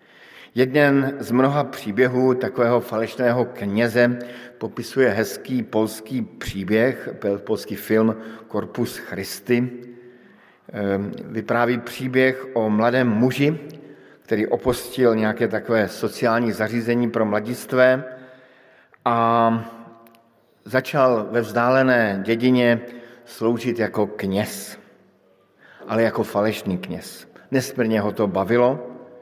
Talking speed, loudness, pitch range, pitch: 90 wpm, -21 LUFS, 110-125 Hz, 120 Hz